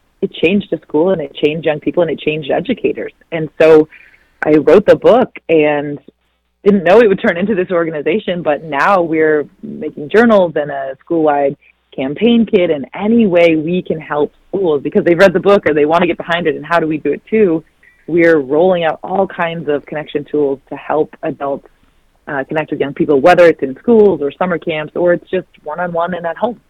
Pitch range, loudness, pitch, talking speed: 150-185 Hz, -13 LUFS, 165 Hz, 210 wpm